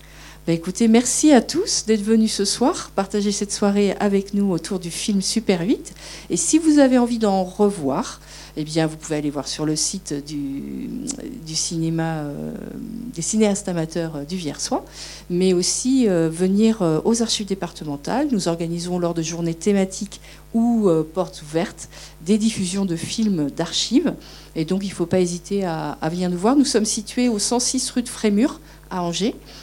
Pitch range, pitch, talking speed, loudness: 165-225 Hz, 190 Hz, 180 wpm, -21 LUFS